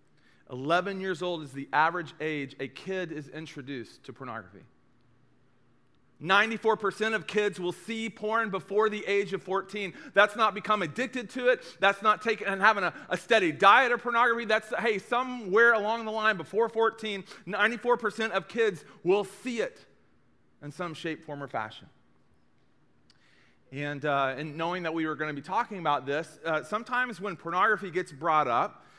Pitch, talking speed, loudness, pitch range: 195 Hz, 170 wpm, -28 LUFS, 160-220 Hz